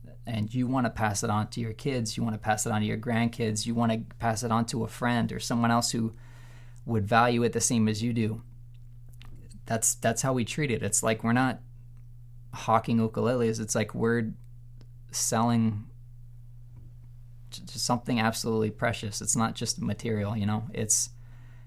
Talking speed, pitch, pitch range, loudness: 185 wpm, 115 Hz, 110-120 Hz, -28 LUFS